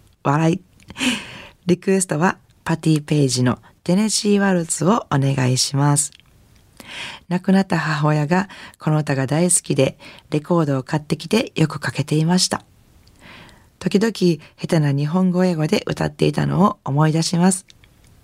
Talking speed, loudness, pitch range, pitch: 290 characters per minute, -19 LUFS, 145-185 Hz, 165 Hz